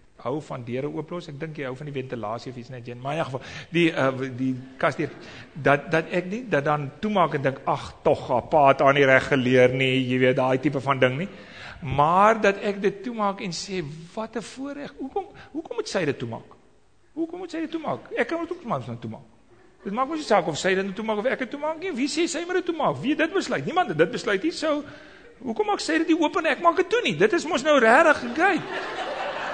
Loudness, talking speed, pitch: -24 LUFS, 235 wpm, 195 Hz